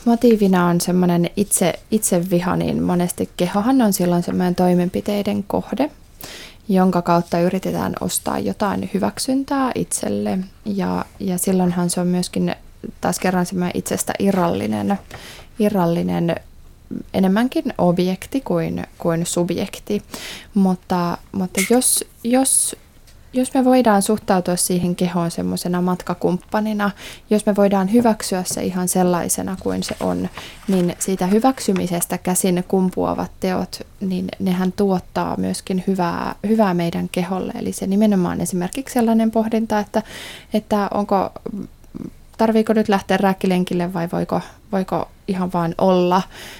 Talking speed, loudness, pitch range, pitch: 120 wpm, -19 LUFS, 175-210 Hz, 185 Hz